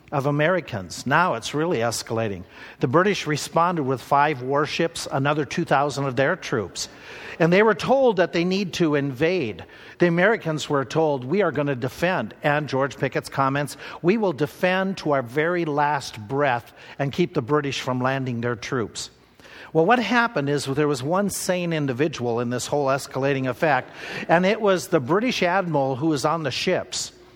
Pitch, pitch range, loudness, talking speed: 150 Hz, 135-175 Hz, -23 LUFS, 175 wpm